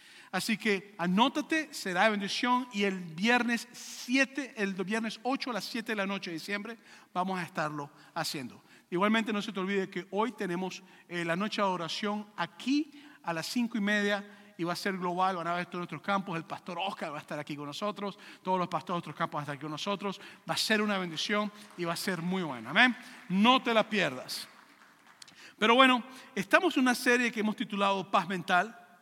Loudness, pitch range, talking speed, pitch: -31 LUFS, 180-230 Hz, 215 wpm, 200 Hz